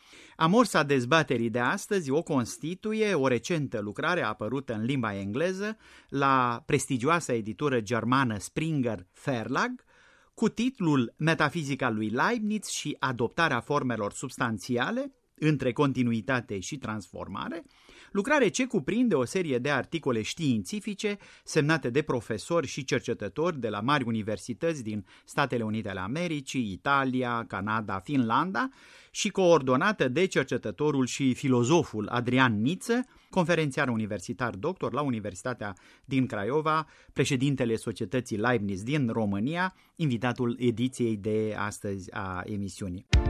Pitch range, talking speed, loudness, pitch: 115-160 Hz, 115 wpm, -28 LUFS, 130 Hz